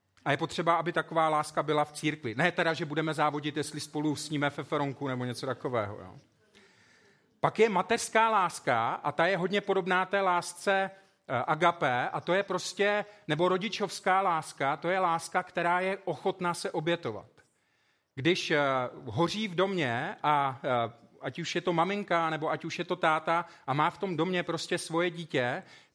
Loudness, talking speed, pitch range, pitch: -30 LUFS, 170 wpm, 150-185 Hz, 165 Hz